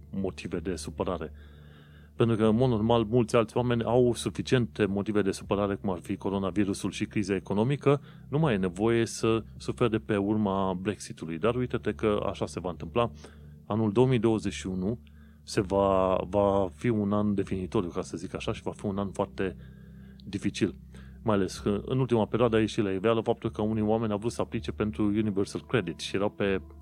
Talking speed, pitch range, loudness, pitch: 190 wpm, 95-115 Hz, -29 LUFS, 105 Hz